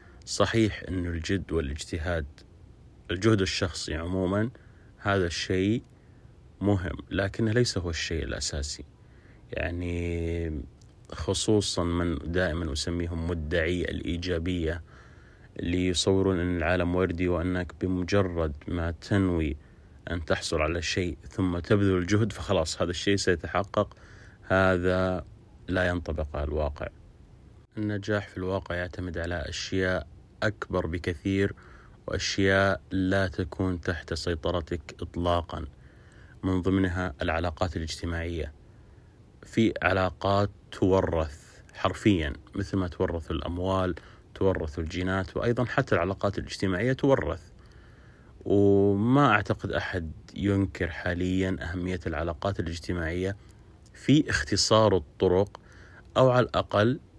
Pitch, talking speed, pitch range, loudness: 90 Hz, 100 wpm, 85-100 Hz, -28 LUFS